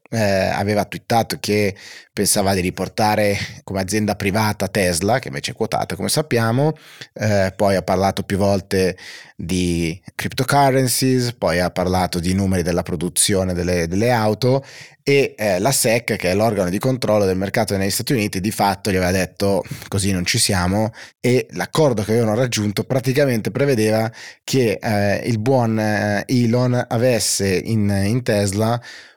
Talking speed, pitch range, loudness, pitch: 155 wpm, 95-120 Hz, -19 LUFS, 105 Hz